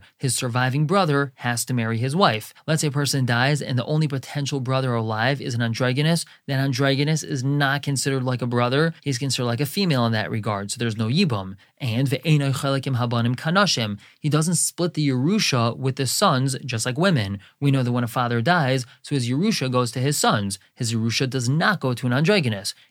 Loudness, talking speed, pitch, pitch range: -22 LUFS, 210 wpm, 135 Hz, 120-145 Hz